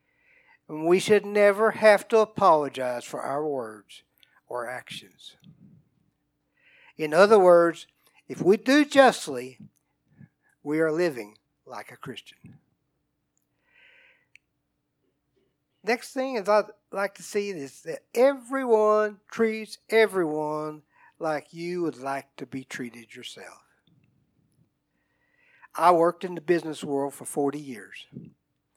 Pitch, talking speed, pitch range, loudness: 175 Hz, 110 wpm, 150-215 Hz, -24 LUFS